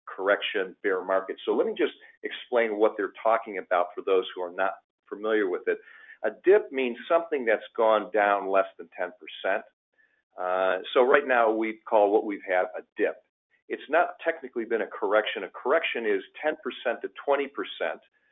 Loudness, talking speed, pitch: -27 LUFS, 175 wpm, 340 Hz